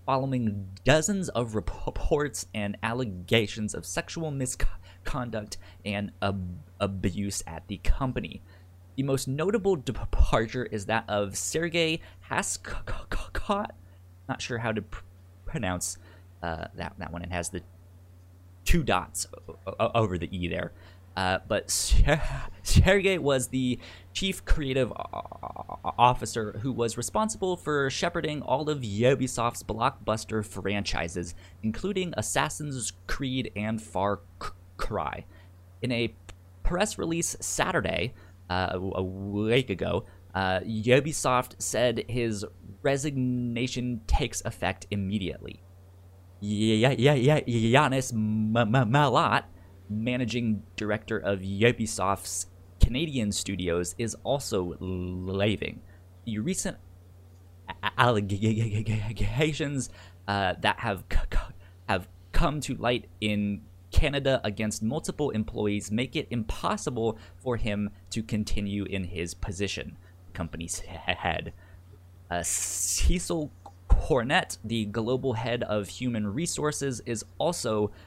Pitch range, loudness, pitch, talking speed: 90-125 Hz, -29 LUFS, 105 Hz, 110 wpm